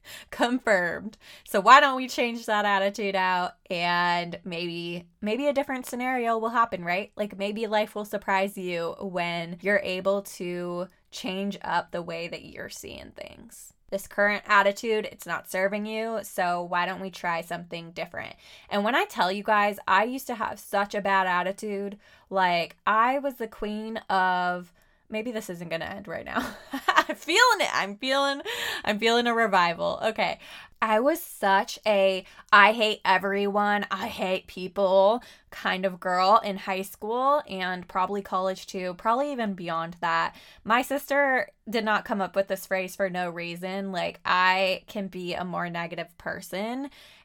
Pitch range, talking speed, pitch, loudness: 185-225 Hz, 170 wpm, 200 Hz, -26 LUFS